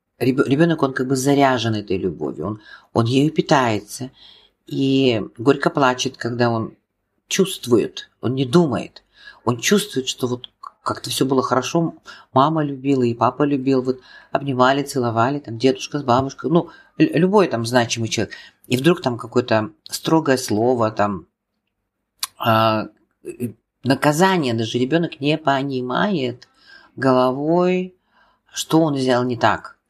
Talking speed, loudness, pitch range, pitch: 130 wpm, -19 LUFS, 120-145 Hz, 130 Hz